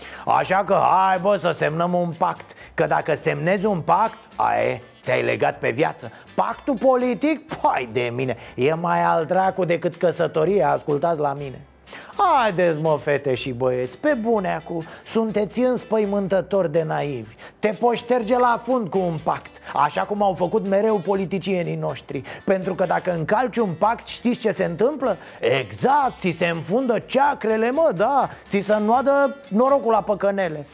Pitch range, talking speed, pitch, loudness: 165-225 Hz, 160 wpm, 195 Hz, -21 LUFS